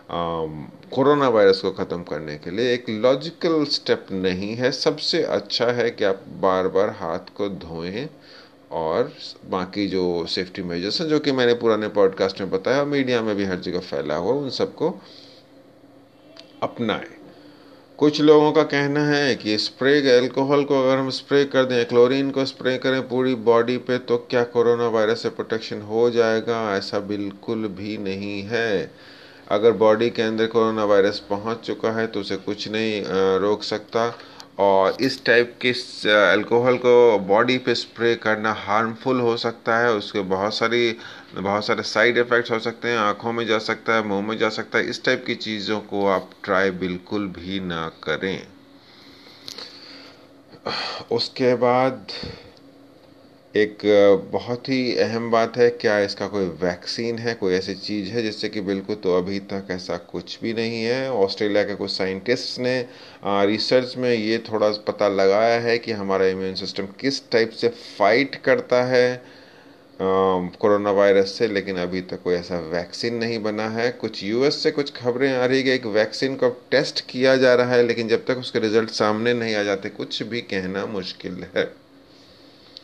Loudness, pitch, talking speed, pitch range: -21 LUFS, 115 Hz, 170 wpm, 100-125 Hz